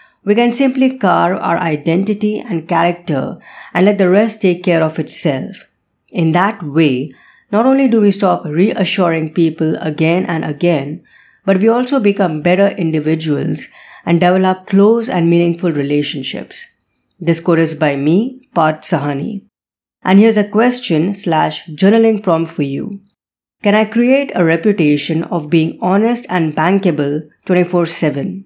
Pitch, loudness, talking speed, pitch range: 175 Hz, -13 LUFS, 145 wpm, 160-205 Hz